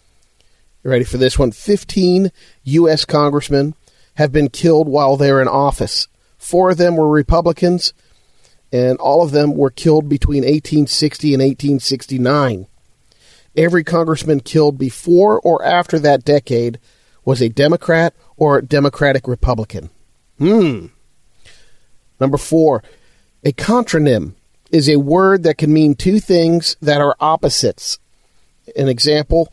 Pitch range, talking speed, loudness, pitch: 135-165 Hz, 125 wpm, -14 LUFS, 145 Hz